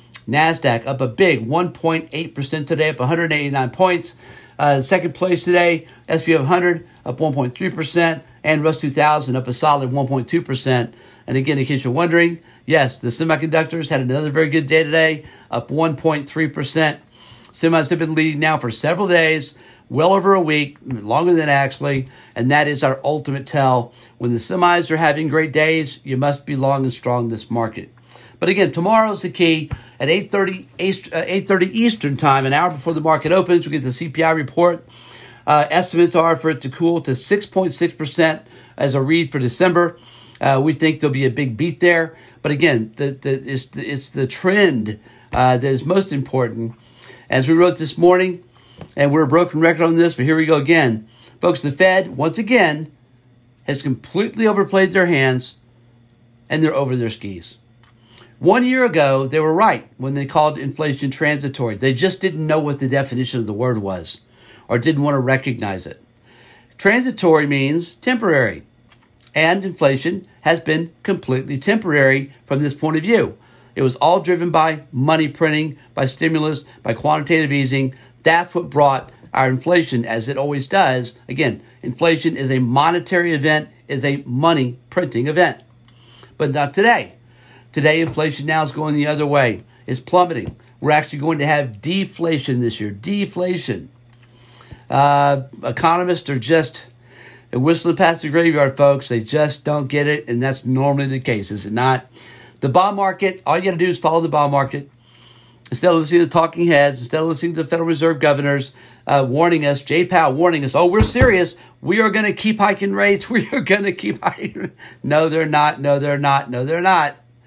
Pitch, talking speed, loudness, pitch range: 145 Hz, 185 wpm, -17 LUFS, 125-165 Hz